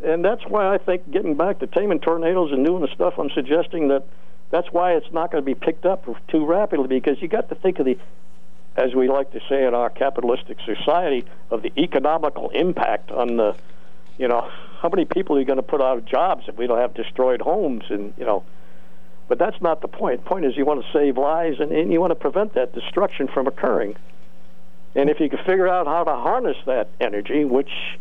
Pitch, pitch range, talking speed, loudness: 160 Hz, 135-180 Hz, 230 wpm, -21 LUFS